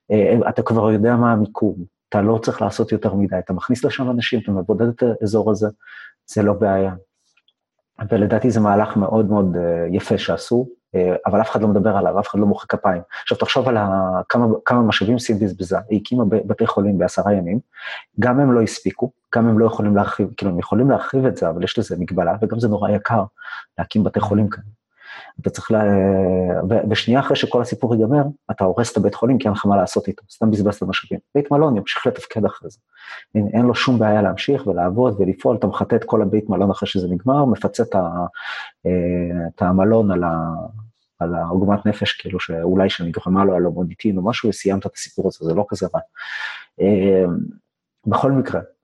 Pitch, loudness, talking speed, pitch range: 105 Hz, -19 LUFS, 195 wpm, 95-115 Hz